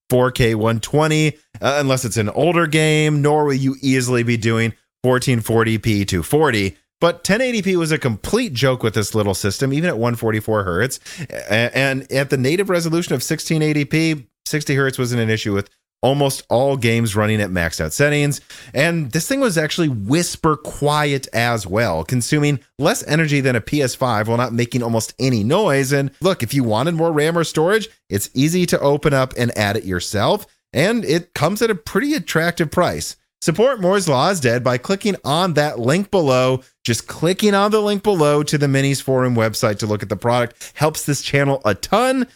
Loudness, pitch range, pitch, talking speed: -18 LUFS, 115-155 Hz, 135 Hz, 185 wpm